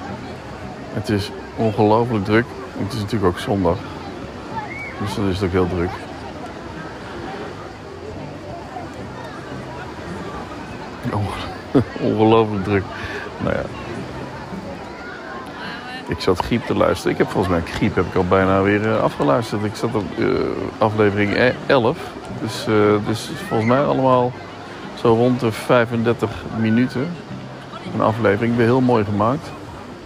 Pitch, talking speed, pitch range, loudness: 105 Hz, 115 wpm, 100-115 Hz, -20 LUFS